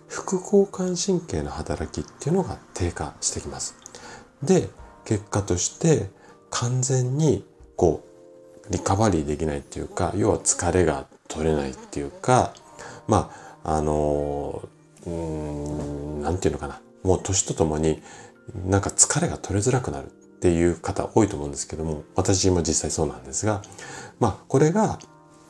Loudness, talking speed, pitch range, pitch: -24 LUFS, 295 characters per minute, 75-110 Hz, 85 Hz